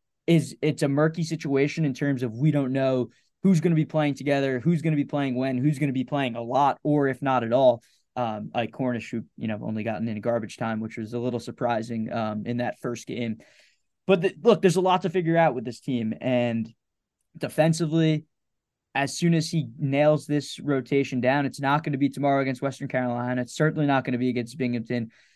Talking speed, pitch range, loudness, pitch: 225 wpm, 120-150 Hz, -25 LUFS, 135 Hz